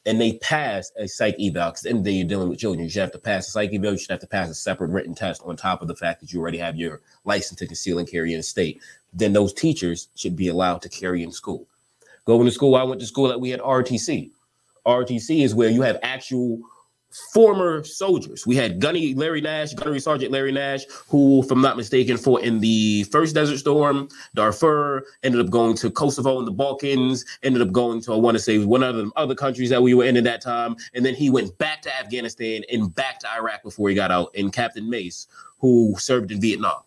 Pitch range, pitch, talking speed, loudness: 105-135 Hz, 120 Hz, 245 wpm, -21 LUFS